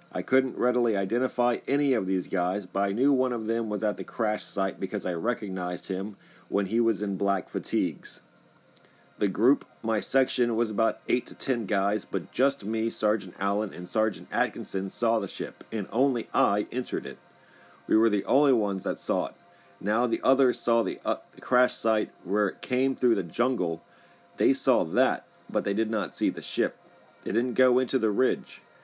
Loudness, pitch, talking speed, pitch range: -27 LUFS, 110 Hz, 195 wpm, 100-125 Hz